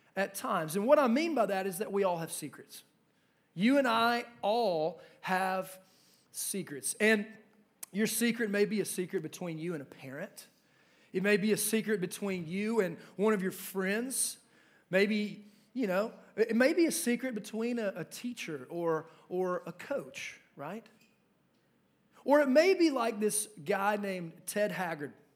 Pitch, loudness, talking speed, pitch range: 205 Hz, -32 LUFS, 170 wpm, 185-225 Hz